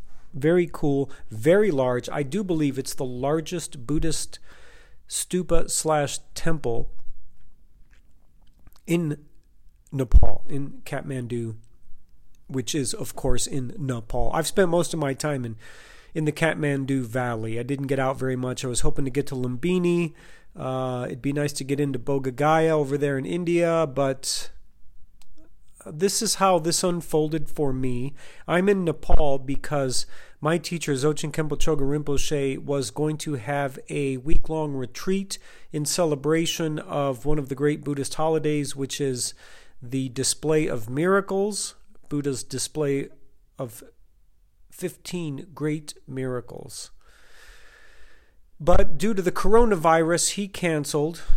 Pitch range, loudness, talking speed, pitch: 135-165 Hz, -25 LUFS, 135 wpm, 145 Hz